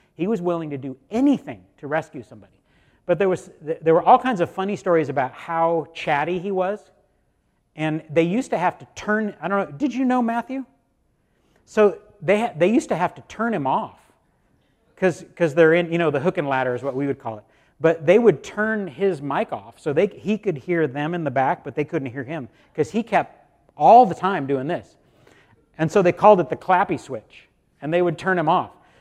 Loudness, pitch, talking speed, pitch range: -21 LUFS, 175 Hz, 220 wpm, 150-200 Hz